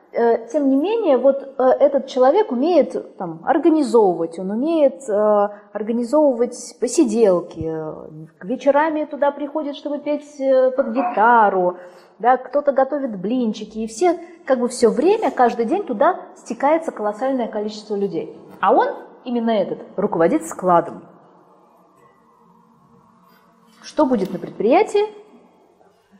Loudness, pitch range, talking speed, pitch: -19 LUFS, 205-290 Hz, 110 wpm, 250 Hz